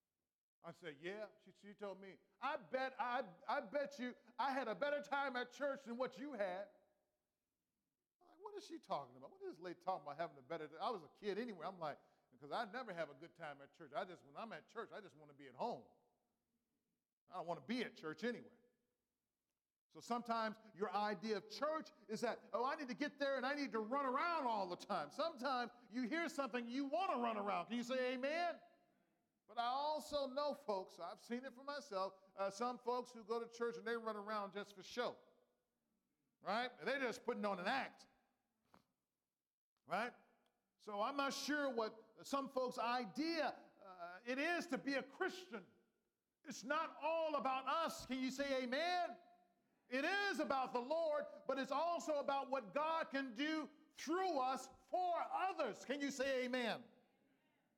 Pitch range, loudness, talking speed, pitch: 215-285 Hz, -44 LUFS, 200 wpm, 255 Hz